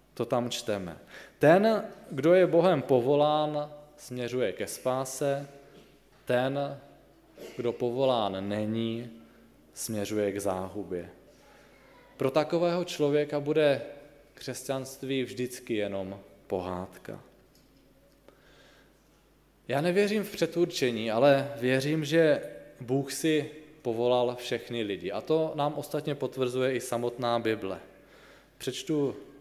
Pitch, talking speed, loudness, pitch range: 130 Hz, 95 wpm, -29 LUFS, 115-150 Hz